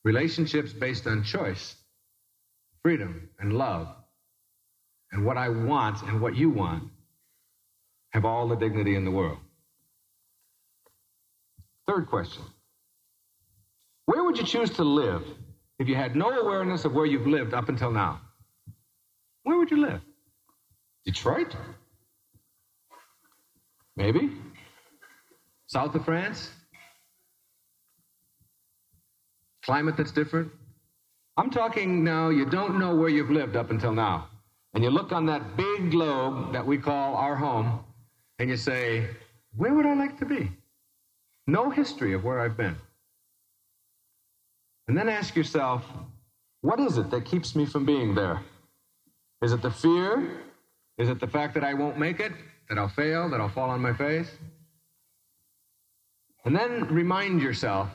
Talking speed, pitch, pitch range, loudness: 135 wpm, 130 Hz, 110-155 Hz, -27 LUFS